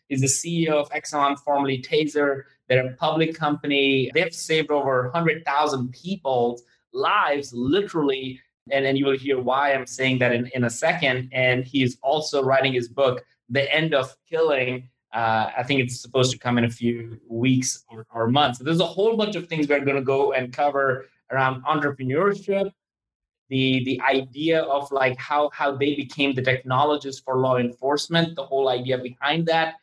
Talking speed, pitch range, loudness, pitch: 180 wpm, 130-150 Hz, -23 LUFS, 135 Hz